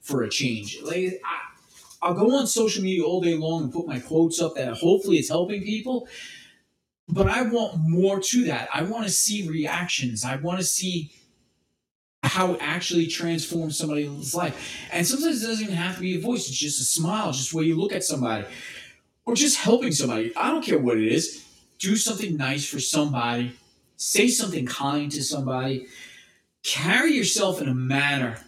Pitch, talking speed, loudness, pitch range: 170 Hz, 190 wpm, -24 LUFS, 140-200 Hz